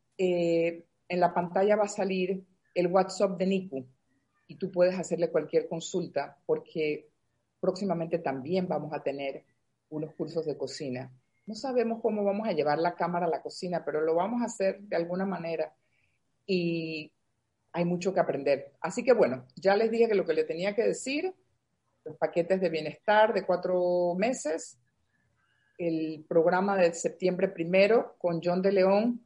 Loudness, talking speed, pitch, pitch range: -29 LUFS, 165 wpm, 175 Hz, 155-195 Hz